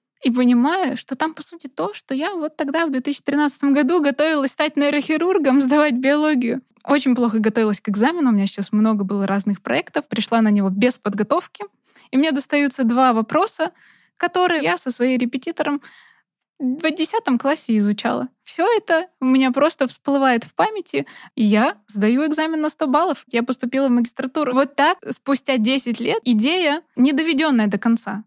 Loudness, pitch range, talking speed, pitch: -19 LUFS, 235-305 Hz, 170 wpm, 270 Hz